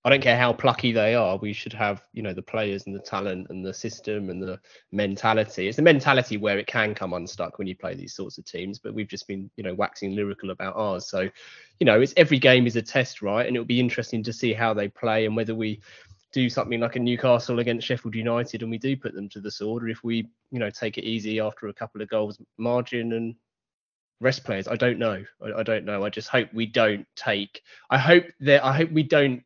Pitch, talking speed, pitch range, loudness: 110 Hz, 255 wpm, 100-120 Hz, -24 LUFS